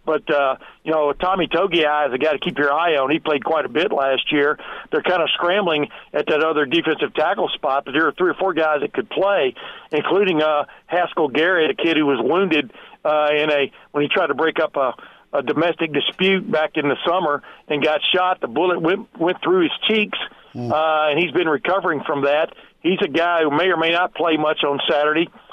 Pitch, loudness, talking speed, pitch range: 155 Hz, -19 LUFS, 225 wpm, 150-185 Hz